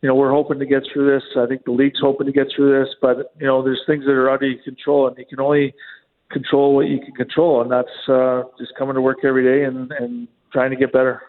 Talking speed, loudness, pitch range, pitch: 275 wpm, -18 LUFS, 130-140 Hz, 135 Hz